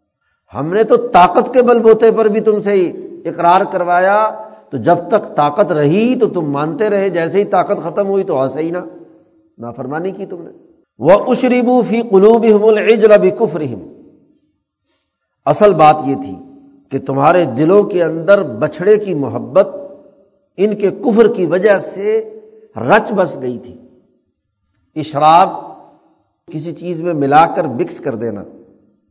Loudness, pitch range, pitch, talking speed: -13 LUFS, 155-220 Hz, 195 Hz, 145 wpm